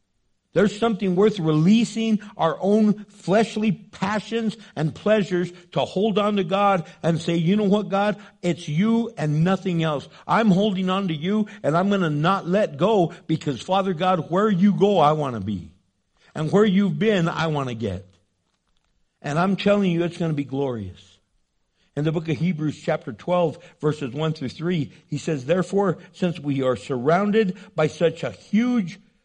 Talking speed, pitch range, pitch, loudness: 180 wpm, 150-200 Hz, 175 Hz, -22 LUFS